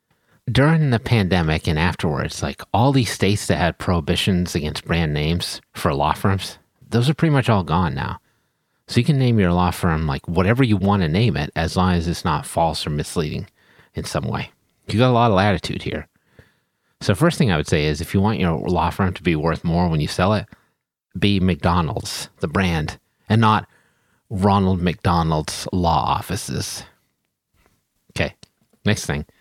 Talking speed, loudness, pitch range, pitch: 185 wpm, -20 LUFS, 85-110 Hz, 95 Hz